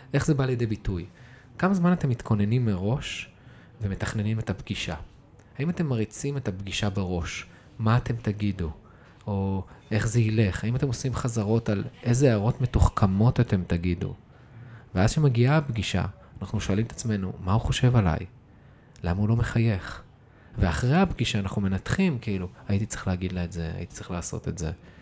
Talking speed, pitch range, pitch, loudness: 160 wpm, 95-125 Hz, 110 Hz, -27 LUFS